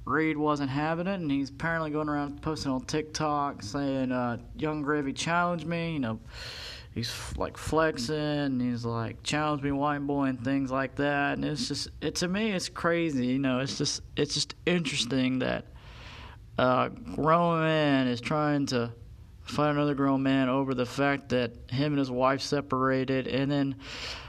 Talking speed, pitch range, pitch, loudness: 180 wpm, 125-150 Hz, 140 Hz, -29 LUFS